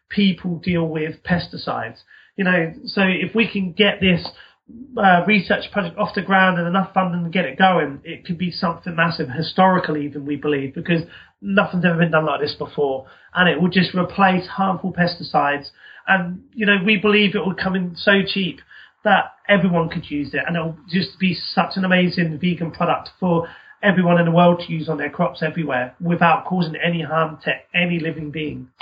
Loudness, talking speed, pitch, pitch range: -19 LUFS, 195 wpm, 175 Hz, 160-190 Hz